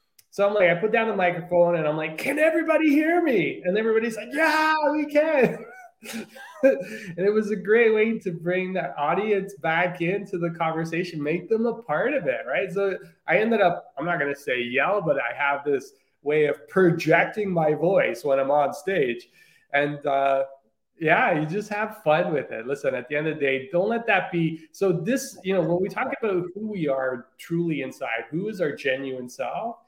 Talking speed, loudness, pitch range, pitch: 205 wpm, -24 LUFS, 155-220 Hz, 180 Hz